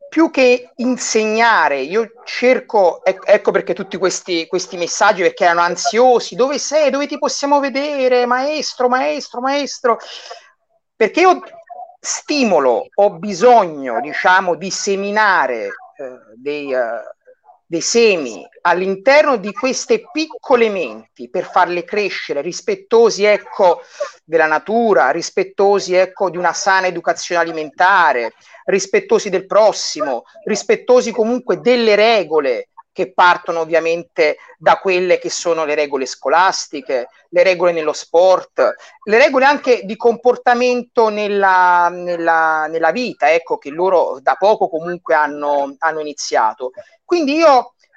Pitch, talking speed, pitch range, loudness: 220 Hz, 120 wpm, 175-280 Hz, -15 LUFS